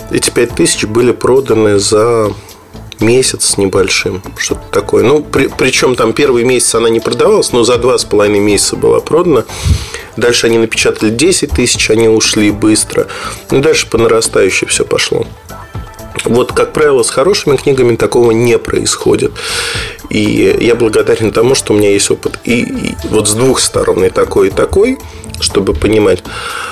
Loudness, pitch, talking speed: -10 LUFS, 125 Hz, 160 wpm